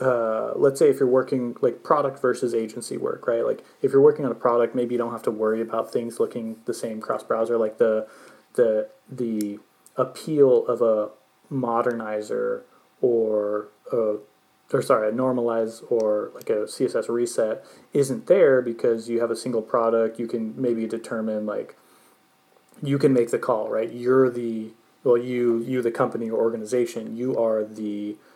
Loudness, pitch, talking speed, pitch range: -24 LUFS, 120 Hz, 170 wpm, 110-135 Hz